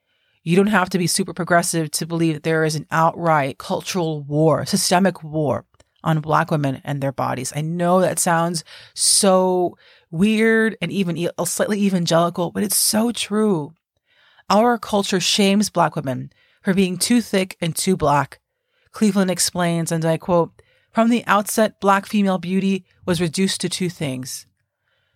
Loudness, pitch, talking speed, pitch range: -19 LUFS, 175 Hz, 155 wpm, 160-195 Hz